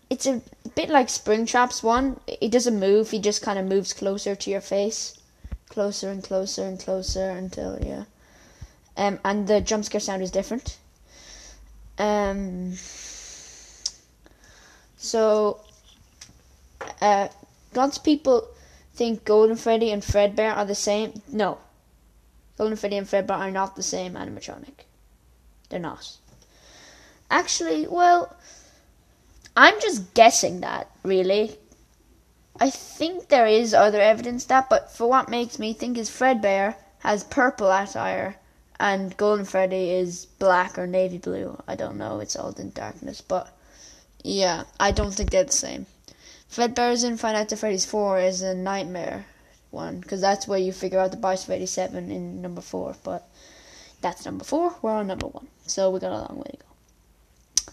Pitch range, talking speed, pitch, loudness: 185-230 Hz, 150 wpm, 205 Hz, -23 LUFS